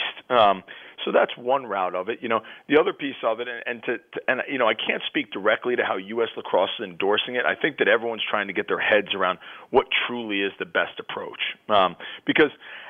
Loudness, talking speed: -24 LUFS, 250 wpm